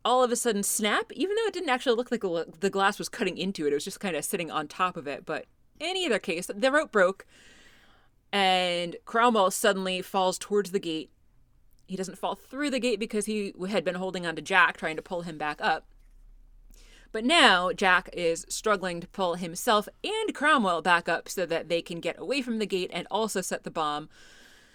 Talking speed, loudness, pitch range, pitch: 215 wpm, -27 LUFS, 175-230 Hz, 190 Hz